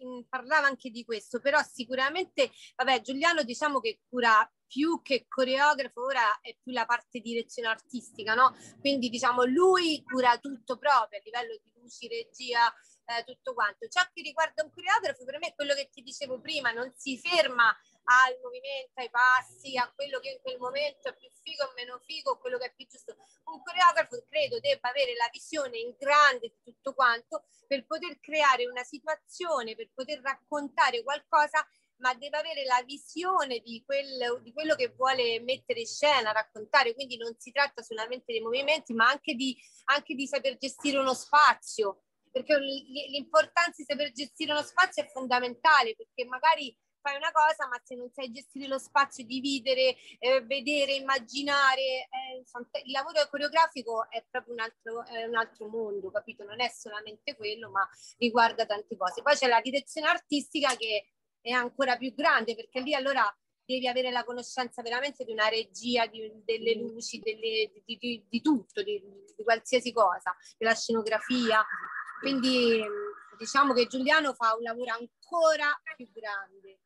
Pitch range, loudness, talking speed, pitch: 235-295 Hz, -29 LUFS, 170 wpm, 260 Hz